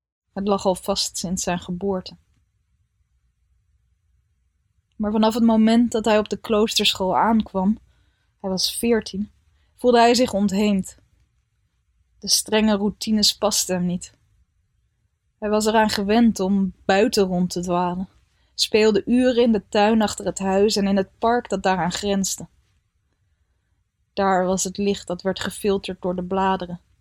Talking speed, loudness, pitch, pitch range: 140 wpm, -21 LUFS, 190 Hz, 165-210 Hz